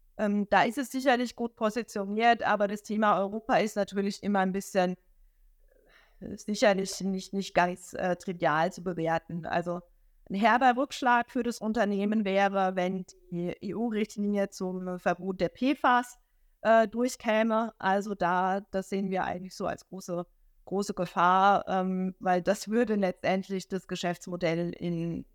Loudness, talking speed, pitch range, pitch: -29 LUFS, 140 wpm, 185-220 Hz, 195 Hz